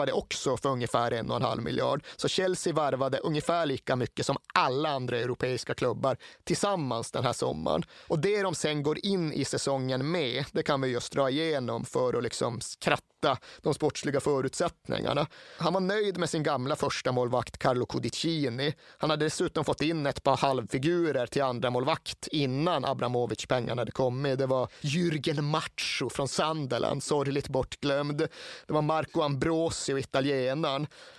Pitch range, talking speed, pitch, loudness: 135-165 Hz, 160 wpm, 150 Hz, -29 LUFS